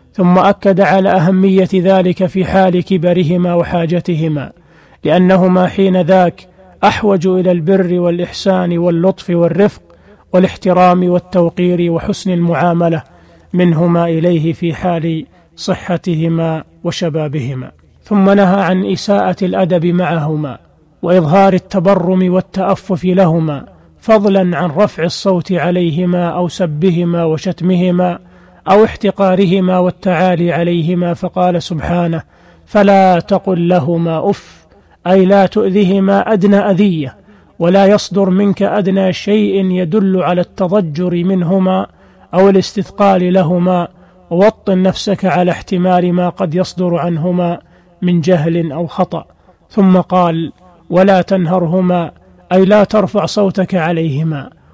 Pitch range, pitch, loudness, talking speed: 175-190 Hz, 180 Hz, -12 LUFS, 105 wpm